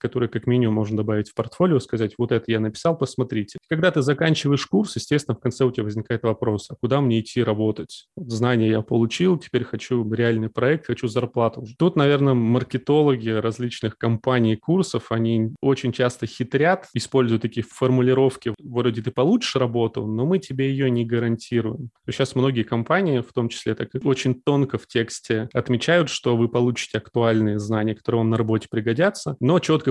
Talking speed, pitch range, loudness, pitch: 175 wpm, 115-135 Hz, -22 LUFS, 120 Hz